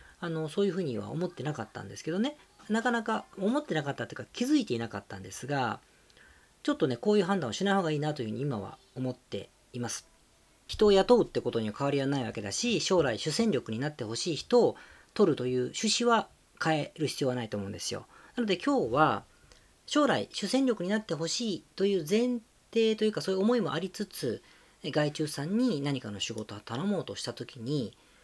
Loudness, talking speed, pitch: -30 LUFS, 425 characters per minute, 160 Hz